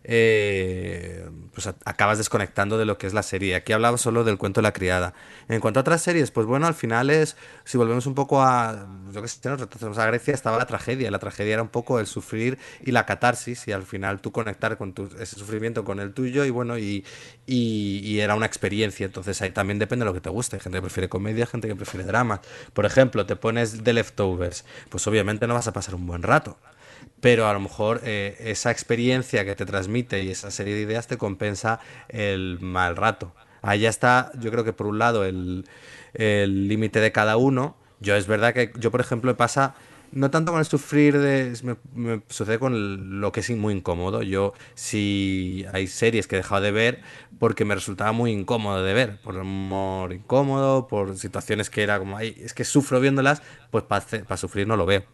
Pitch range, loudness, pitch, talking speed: 100-120 Hz, -24 LUFS, 110 Hz, 220 wpm